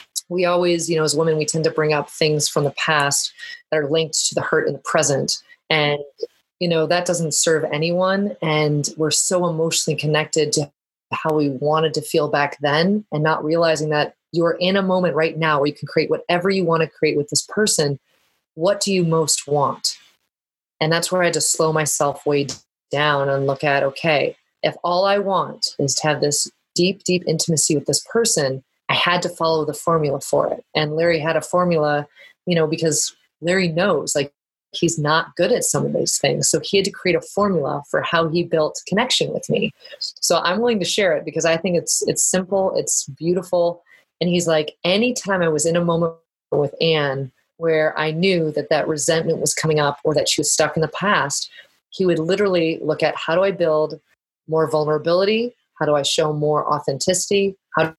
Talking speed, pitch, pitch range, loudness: 205 wpm, 160 Hz, 150-175 Hz, -19 LUFS